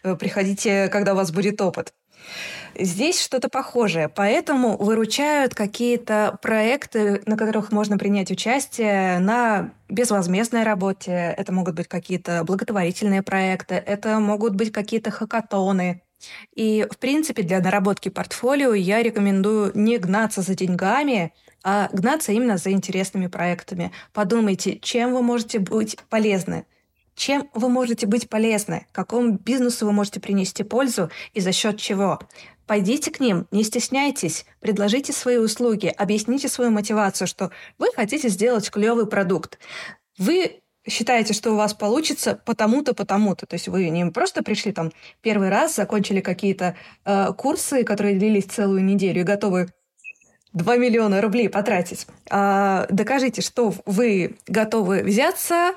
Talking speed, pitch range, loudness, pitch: 135 wpm, 195-235 Hz, -21 LUFS, 210 Hz